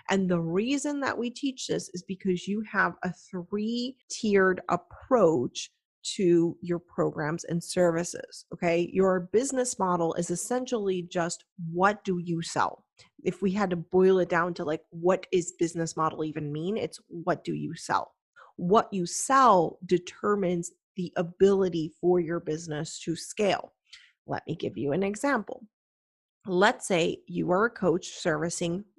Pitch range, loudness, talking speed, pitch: 170-205 Hz, -28 LUFS, 155 wpm, 180 Hz